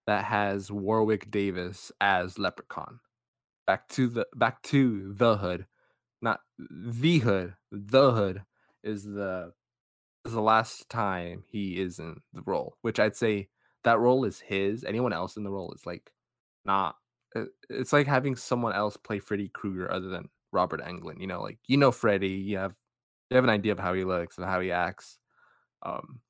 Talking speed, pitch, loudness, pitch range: 180 wpm, 100 Hz, -29 LUFS, 95-115 Hz